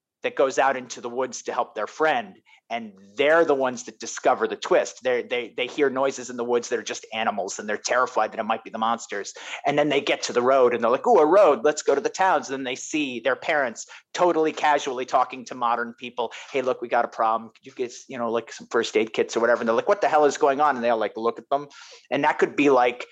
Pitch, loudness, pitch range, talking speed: 135 Hz, -23 LUFS, 120-175 Hz, 280 wpm